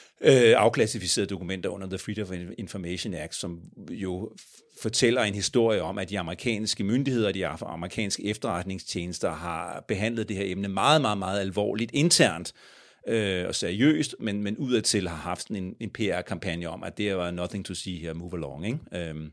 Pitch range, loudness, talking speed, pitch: 90-110 Hz, -27 LUFS, 170 wpm, 100 Hz